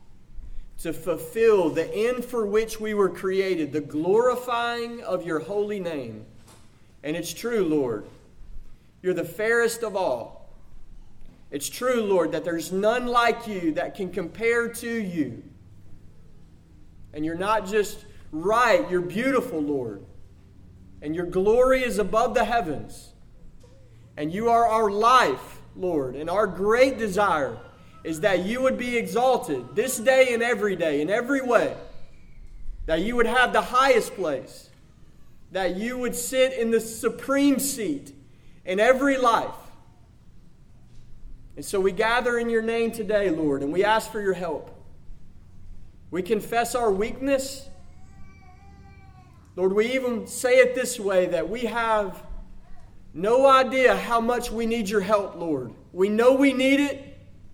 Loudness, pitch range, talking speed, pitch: -24 LUFS, 150-235 Hz, 145 wpm, 210 Hz